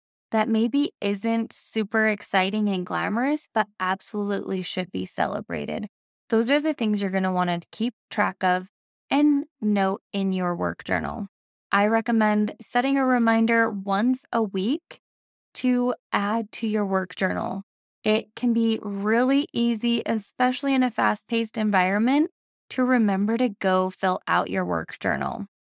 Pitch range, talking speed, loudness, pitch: 195-235 Hz, 150 wpm, -24 LUFS, 220 Hz